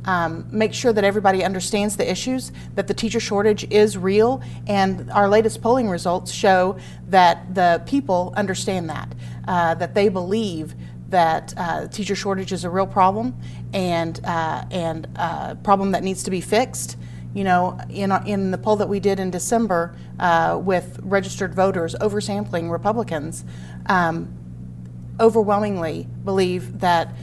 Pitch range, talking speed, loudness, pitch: 160-205 Hz, 150 wpm, -21 LUFS, 185 Hz